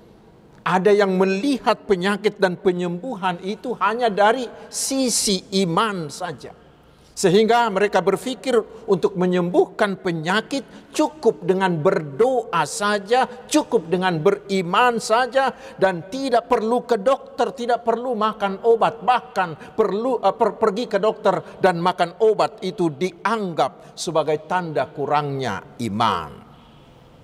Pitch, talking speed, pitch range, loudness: 210 Hz, 110 wpm, 185-235 Hz, -21 LUFS